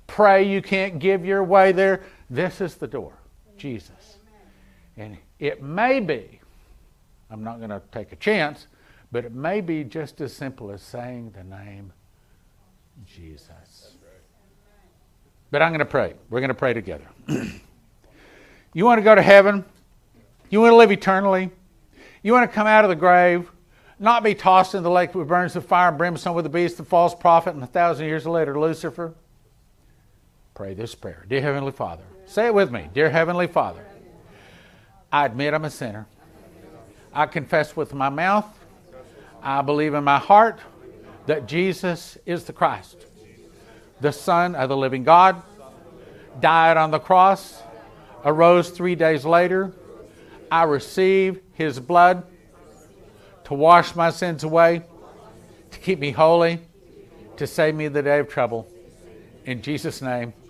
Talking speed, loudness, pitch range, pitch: 160 wpm, -19 LUFS, 125-180 Hz, 160 Hz